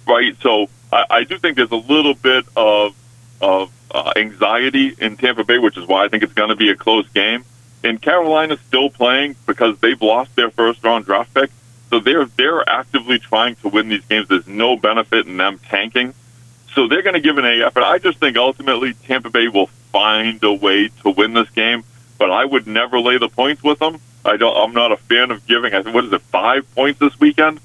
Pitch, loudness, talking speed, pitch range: 120 Hz, -15 LUFS, 220 wpm, 115-135 Hz